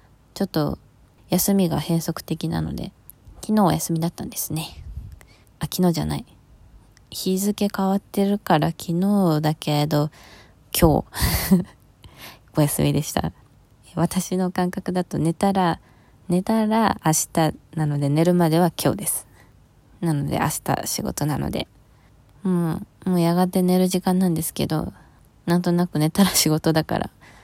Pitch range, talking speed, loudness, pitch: 145-185 Hz, 260 characters per minute, -22 LUFS, 165 Hz